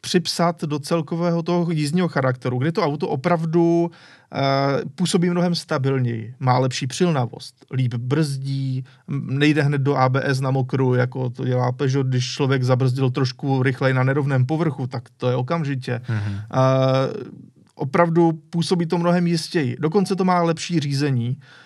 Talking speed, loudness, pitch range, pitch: 145 wpm, -21 LUFS, 130-170 Hz, 140 Hz